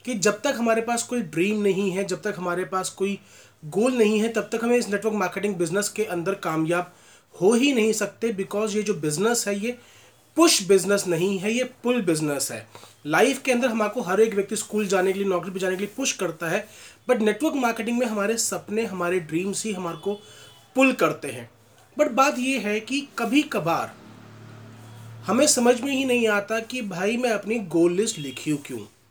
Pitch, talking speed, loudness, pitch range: 205 Hz, 205 wpm, -23 LUFS, 175-235 Hz